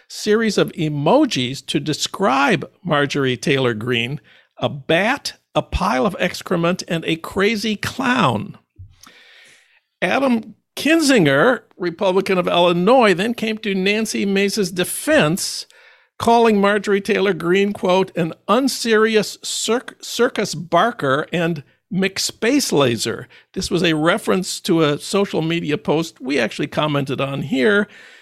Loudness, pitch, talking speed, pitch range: -18 LUFS, 190 Hz, 120 wpm, 155-215 Hz